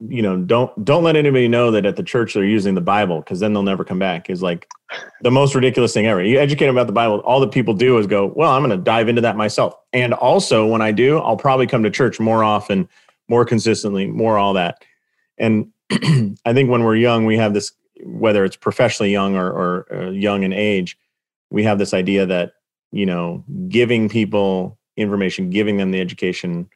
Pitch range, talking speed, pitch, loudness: 100-120 Hz, 220 wpm, 110 Hz, -17 LUFS